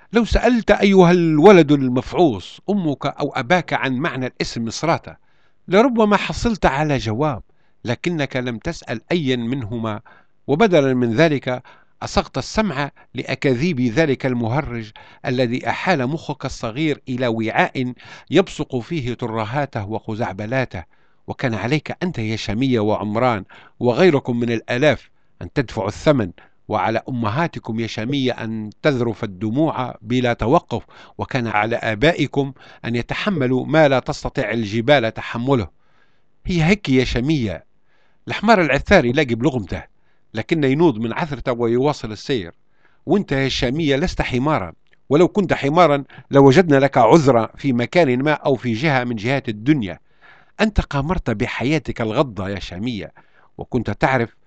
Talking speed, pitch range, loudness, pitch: 125 wpm, 115-155 Hz, -19 LUFS, 130 Hz